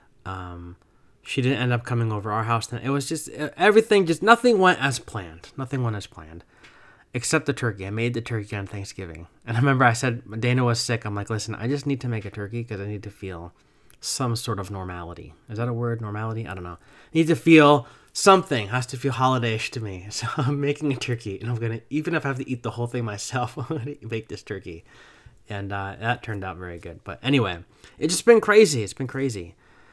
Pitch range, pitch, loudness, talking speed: 100-135 Hz, 120 Hz, -23 LUFS, 235 wpm